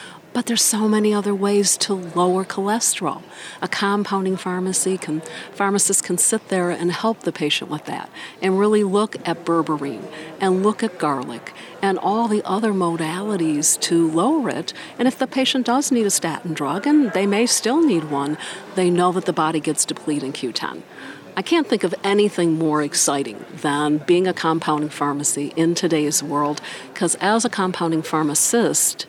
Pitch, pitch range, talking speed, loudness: 180 Hz, 155-205 Hz, 175 wpm, -20 LUFS